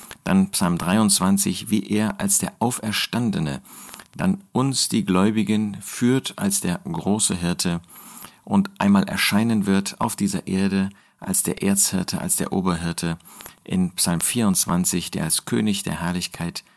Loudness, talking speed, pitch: -21 LUFS, 135 wpm, 110 Hz